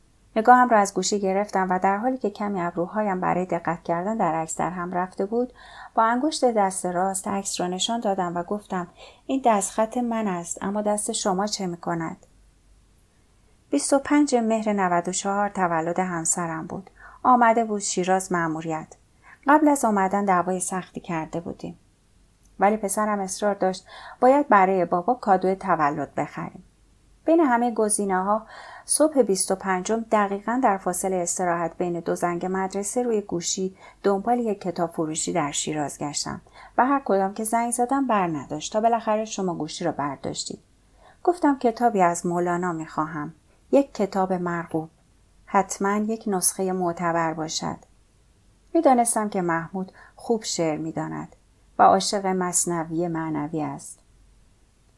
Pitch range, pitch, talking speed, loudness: 170-220 Hz, 190 Hz, 145 wpm, -24 LUFS